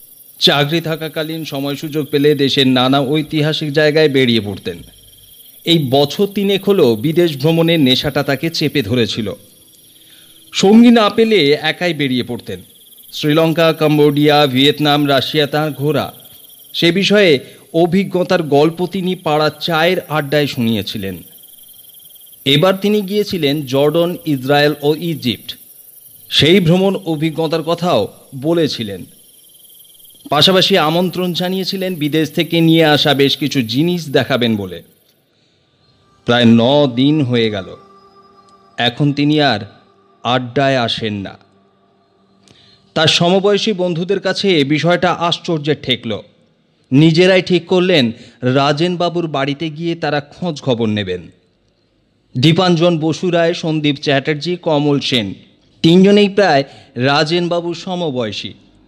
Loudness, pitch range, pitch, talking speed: -14 LUFS, 135-175 Hz, 150 Hz, 110 wpm